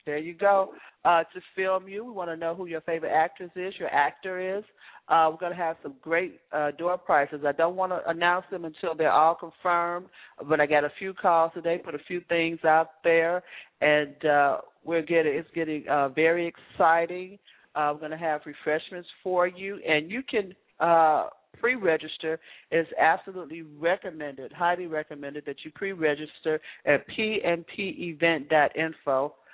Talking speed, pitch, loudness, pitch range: 165 wpm, 165 Hz, -26 LUFS, 155-180 Hz